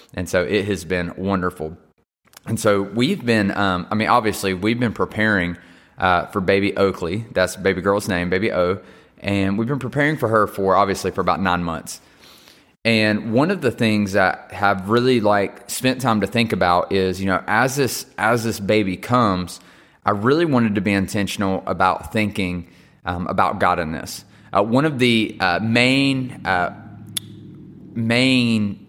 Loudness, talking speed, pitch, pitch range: -20 LUFS, 175 wpm, 100 Hz, 90-115 Hz